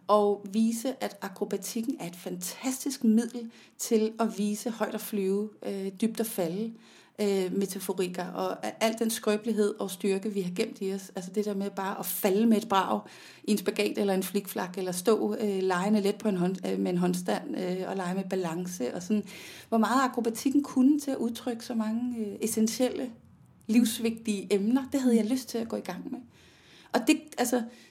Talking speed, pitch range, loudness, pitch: 200 wpm, 195-230 Hz, -29 LUFS, 210 Hz